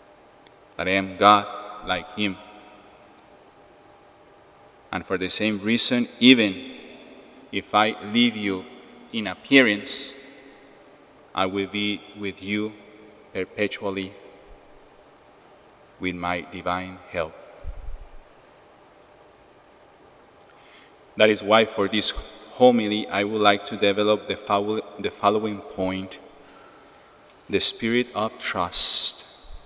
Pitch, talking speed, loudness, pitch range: 105 Hz, 95 wpm, -21 LUFS, 100-110 Hz